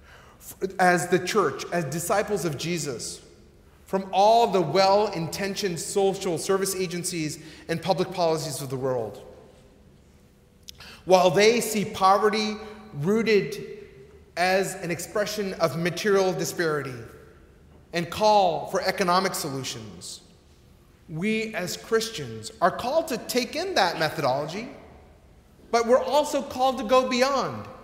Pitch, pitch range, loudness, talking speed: 190 Hz, 170-215 Hz, -24 LUFS, 115 wpm